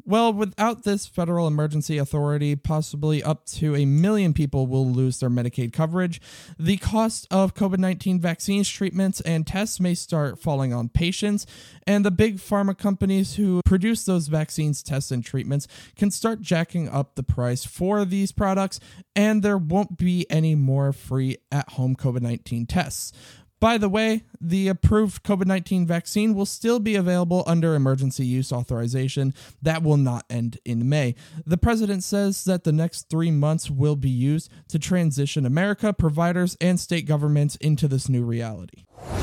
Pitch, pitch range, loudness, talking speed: 160 Hz, 135-195 Hz, -23 LUFS, 165 wpm